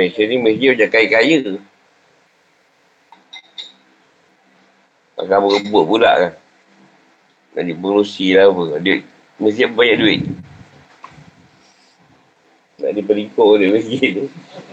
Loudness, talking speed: -14 LUFS, 100 wpm